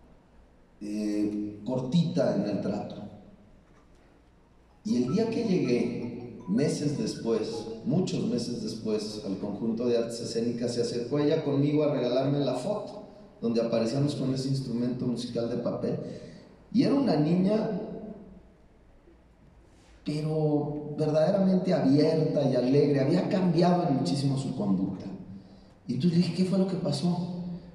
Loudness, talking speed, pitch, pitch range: -28 LUFS, 125 wpm, 140 Hz, 115-175 Hz